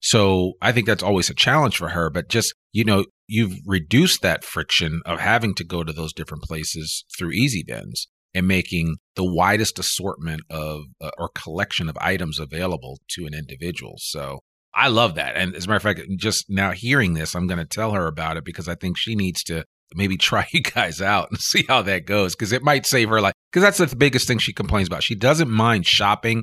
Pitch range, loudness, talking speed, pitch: 80-110 Hz, -21 LUFS, 225 wpm, 95 Hz